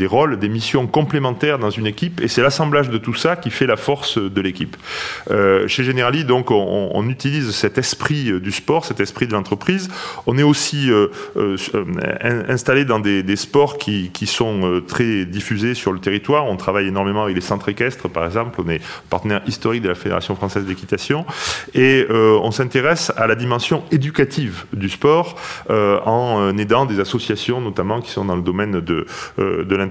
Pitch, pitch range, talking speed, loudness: 110 Hz, 100-130 Hz, 195 wpm, -18 LUFS